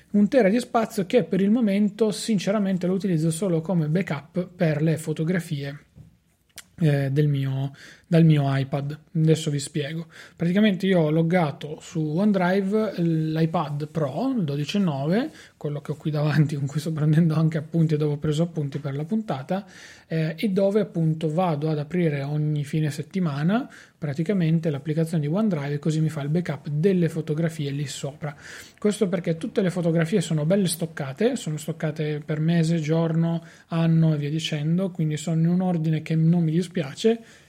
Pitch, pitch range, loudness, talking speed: 165 Hz, 150-185 Hz, -24 LUFS, 165 wpm